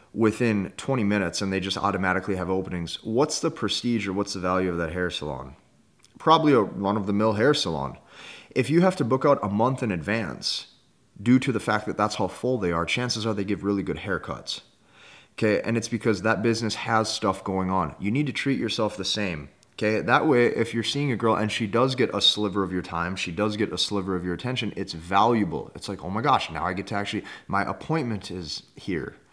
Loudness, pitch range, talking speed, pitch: -25 LUFS, 95-115 Hz, 230 wpm, 105 Hz